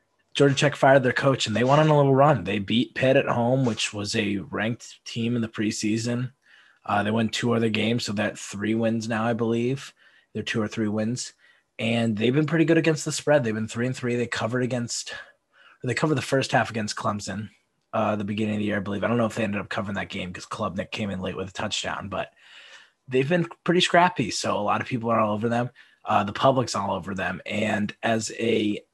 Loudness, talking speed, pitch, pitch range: -24 LUFS, 240 wpm, 115 Hz, 105-130 Hz